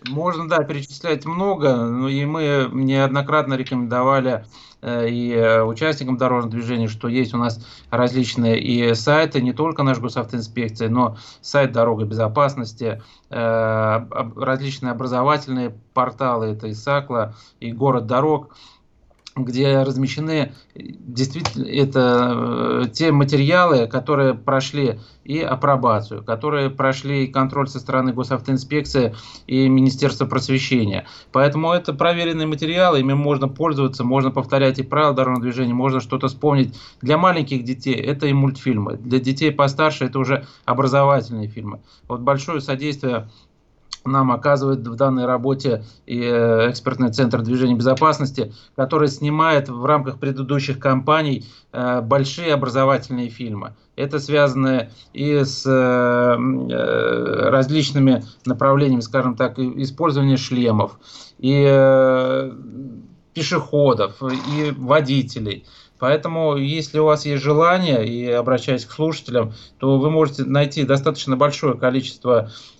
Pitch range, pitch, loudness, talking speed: 120-140 Hz, 130 Hz, -19 LUFS, 120 wpm